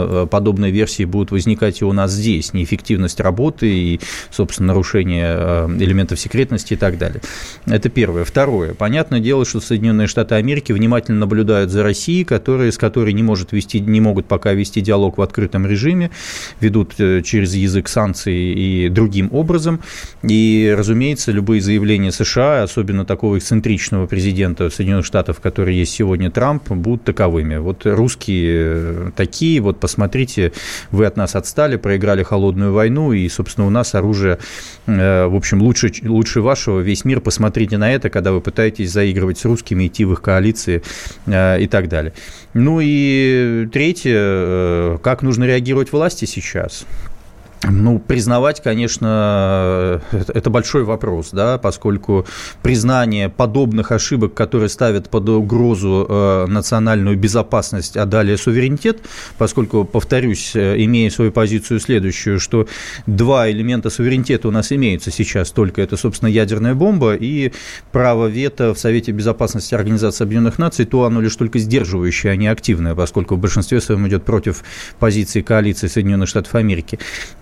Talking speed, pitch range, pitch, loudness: 145 wpm, 95-115 Hz, 105 Hz, -16 LUFS